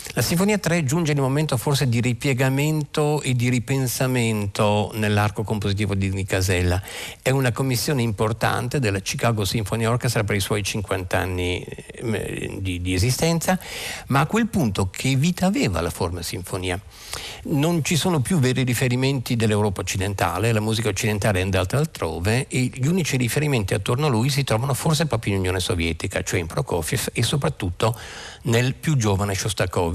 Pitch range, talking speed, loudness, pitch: 100-135 Hz, 160 wpm, -22 LUFS, 115 Hz